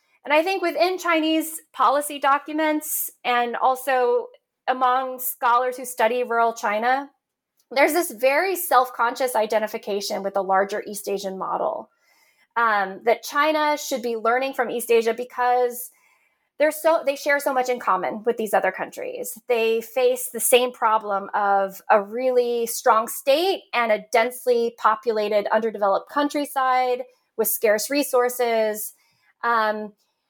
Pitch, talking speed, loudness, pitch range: 245 Hz, 135 wpm, -22 LUFS, 220-275 Hz